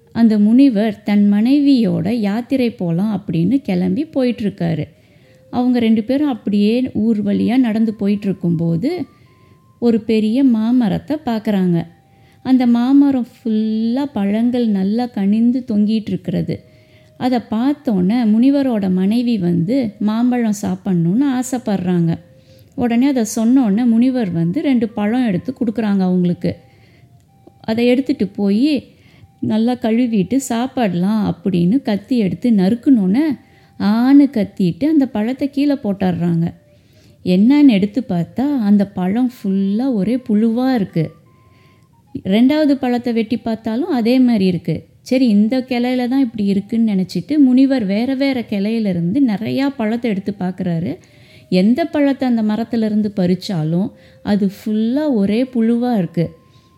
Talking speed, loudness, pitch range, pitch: 110 wpm, -16 LUFS, 190-250 Hz, 220 Hz